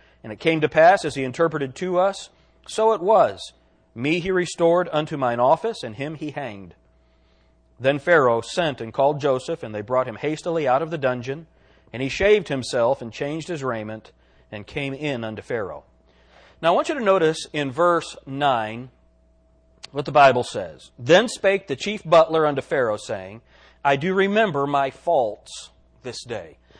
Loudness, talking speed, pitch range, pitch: -21 LUFS, 175 wpm, 115-170 Hz, 140 Hz